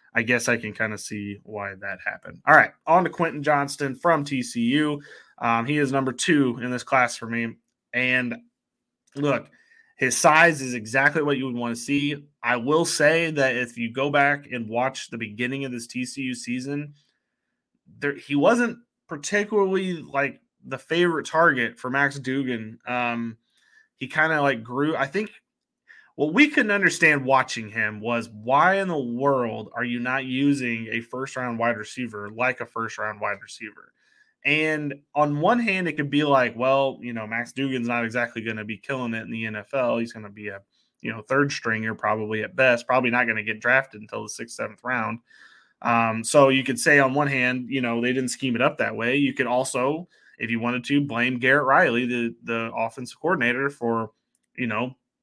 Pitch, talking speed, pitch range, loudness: 130 Hz, 195 wpm, 115-145 Hz, -23 LUFS